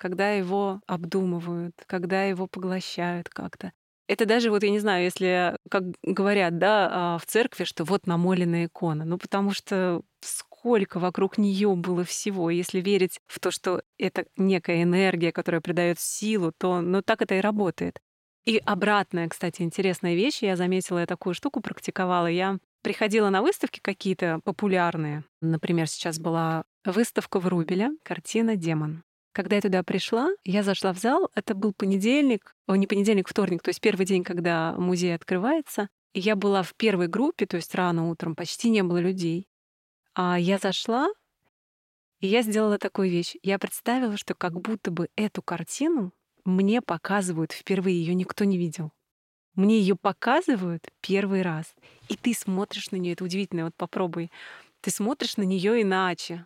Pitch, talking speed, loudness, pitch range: 190 Hz, 160 wpm, -26 LUFS, 175-205 Hz